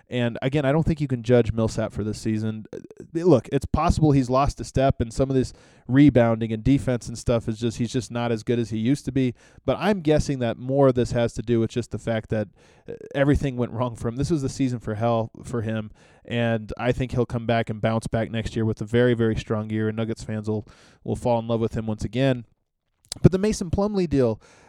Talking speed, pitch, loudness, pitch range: 250 wpm, 120 Hz, -24 LUFS, 110-135 Hz